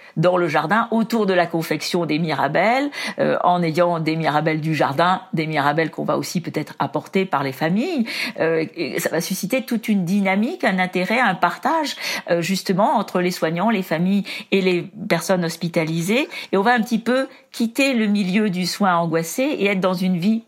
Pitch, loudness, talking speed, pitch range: 185 Hz, -20 LUFS, 195 wpm, 165-220 Hz